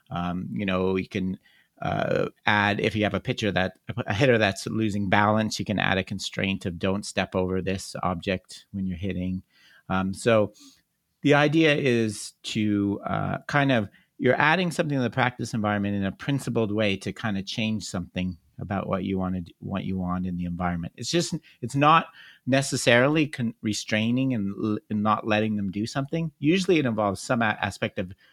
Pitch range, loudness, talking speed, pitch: 95-125 Hz, -25 LUFS, 195 wpm, 105 Hz